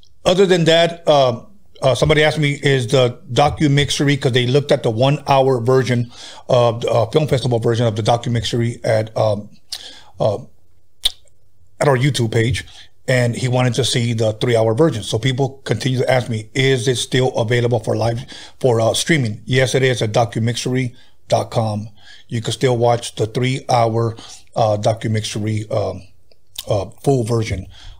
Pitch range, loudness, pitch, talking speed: 115-135 Hz, -17 LUFS, 120 Hz, 160 wpm